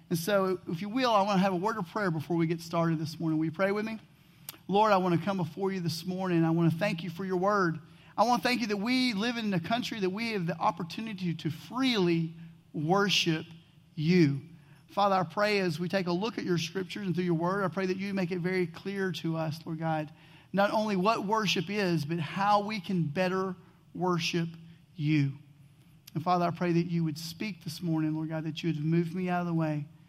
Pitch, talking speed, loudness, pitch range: 175 Hz, 240 wpm, -30 LUFS, 160-195 Hz